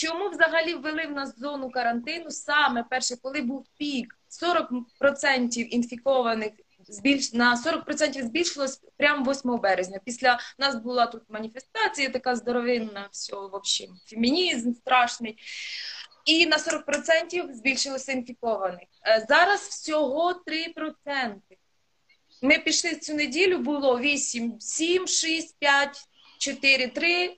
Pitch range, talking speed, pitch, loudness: 245-310 Hz, 110 wpm, 275 Hz, -25 LUFS